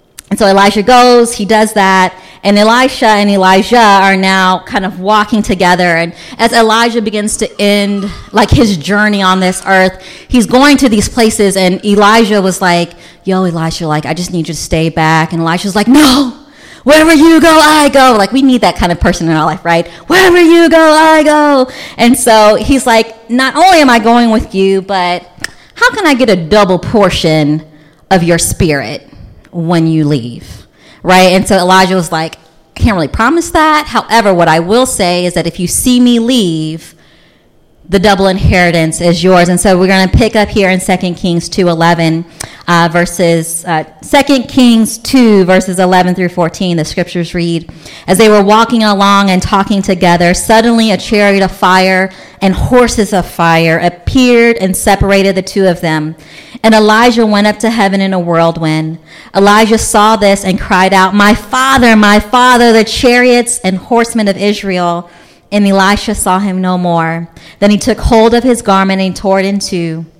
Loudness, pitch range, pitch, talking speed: -8 LUFS, 175-225 Hz, 195 Hz, 185 wpm